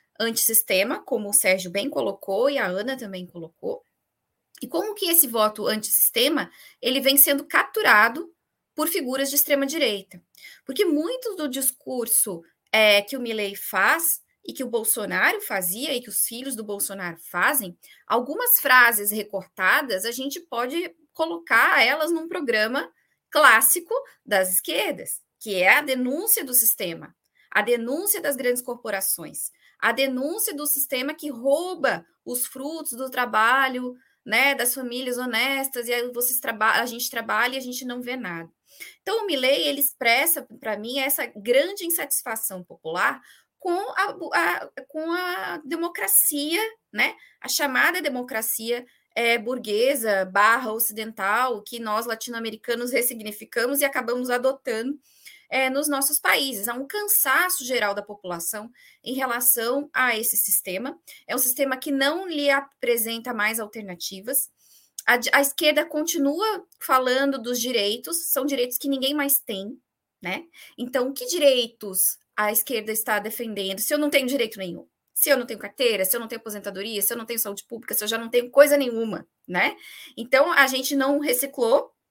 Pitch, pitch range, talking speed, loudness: 255 Hz, 225-285 Hz, 155 wpm, -22 LUFS